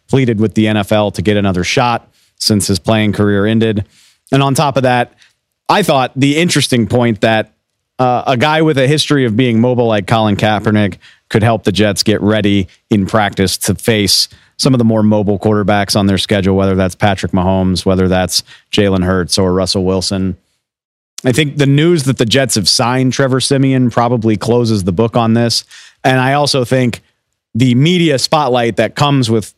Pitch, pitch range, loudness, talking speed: 110 Hz, 100-130 Hz, -12 LUFS, 190 wpm